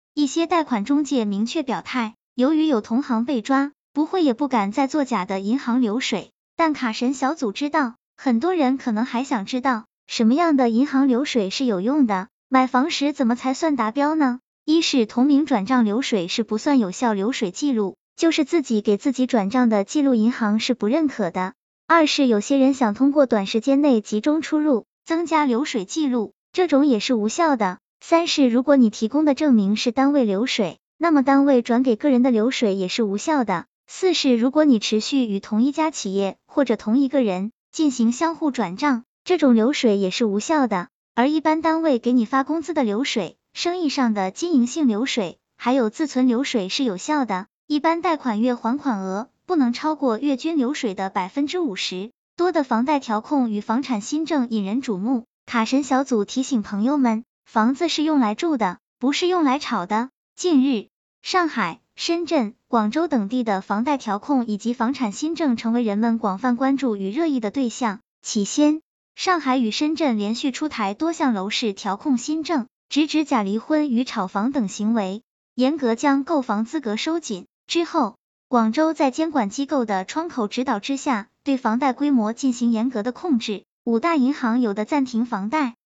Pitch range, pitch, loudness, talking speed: 225-290 Hz, 255 Hz, -21 LUFS, 280 characters per minute